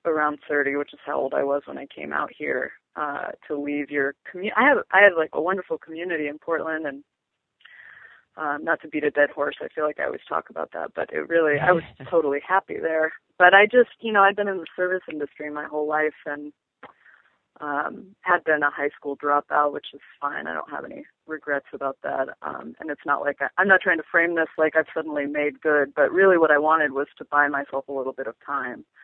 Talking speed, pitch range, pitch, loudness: 240 wpm, 145-175 Hz, 150 Hz, -23 LUFS